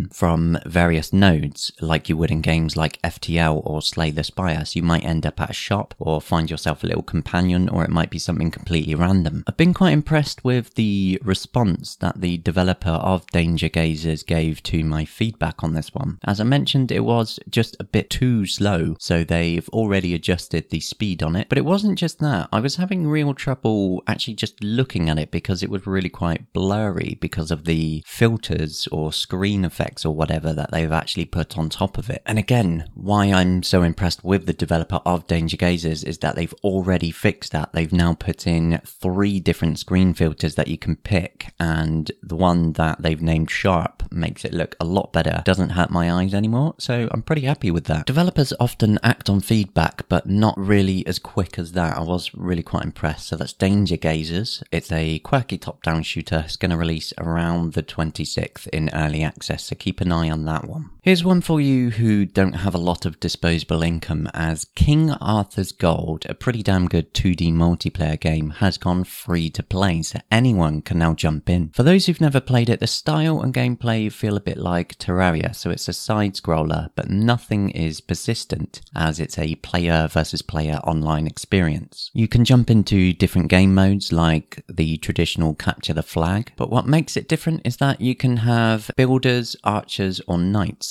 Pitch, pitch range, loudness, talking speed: 90 Hz, 80-105 Hz, -21 LUFS, 200 wpm